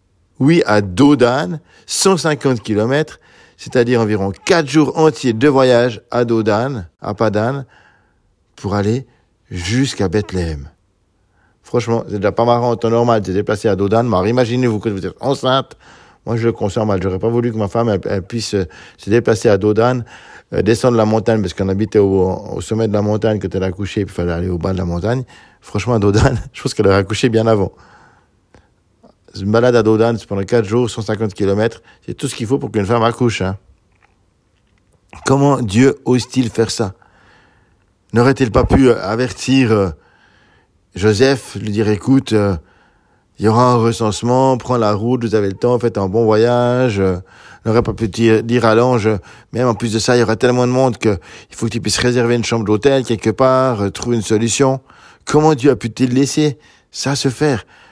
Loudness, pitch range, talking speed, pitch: -15 LUFS, 105-125 Hz, 190 wpm, 115 Hz